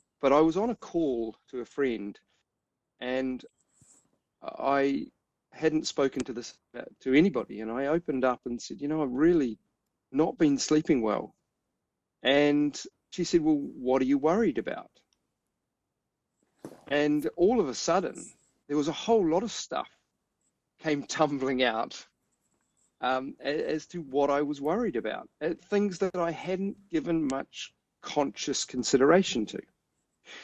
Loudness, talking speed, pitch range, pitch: -28 LUFS, 145 wpm, 130-175 Hz, 150 Hz